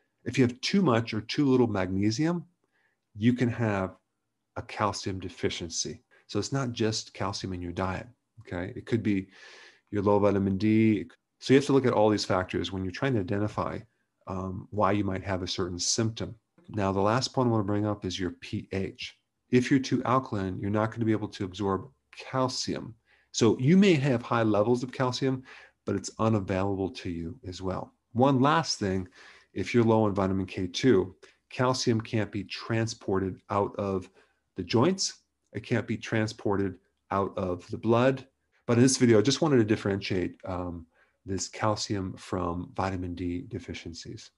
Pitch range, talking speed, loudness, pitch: 95-125 Hz, 185 wpm, -28 LUFS, 105 Hz